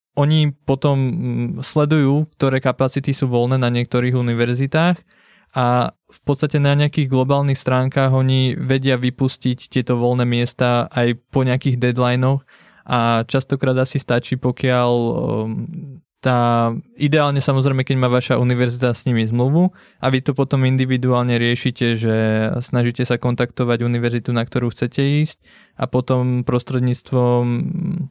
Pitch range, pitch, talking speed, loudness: 120-140 Hz, 130 Hz, 130 wpm, -18 LUFS